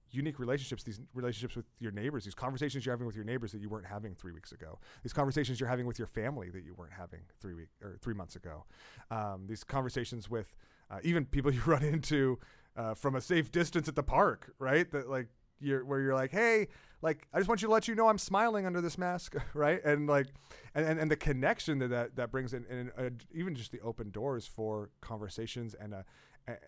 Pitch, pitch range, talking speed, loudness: 130 Hz, 110-145 Hz, 235 wpm, -35 LUFS